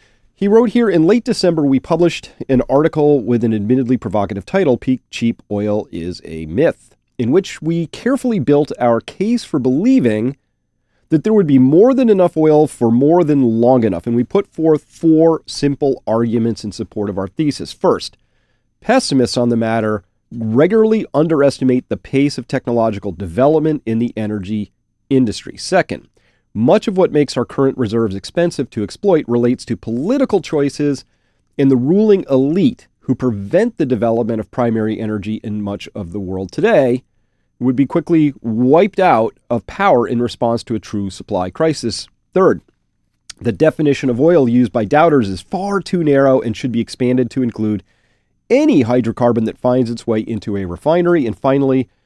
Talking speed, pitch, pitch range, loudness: 170 wpm, 125 Hz, 110-150 Hz, -15 LUFS